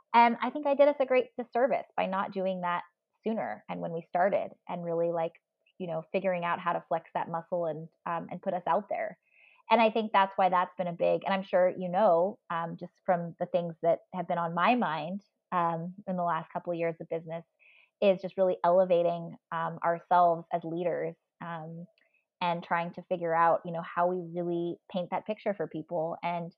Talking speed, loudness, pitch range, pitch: 215 wpm, -30 LUFS, 170-195 Hz, 175 Hz